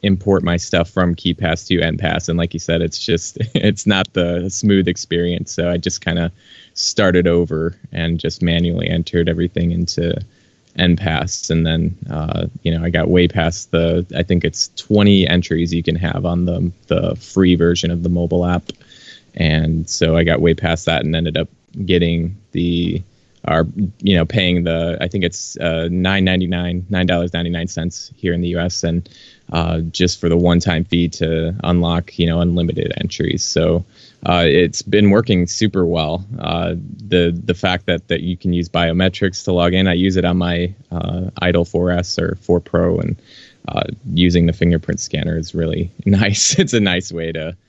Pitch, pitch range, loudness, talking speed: 85 Hz, 85-90 Hz, -17 LUFS, 195 wpm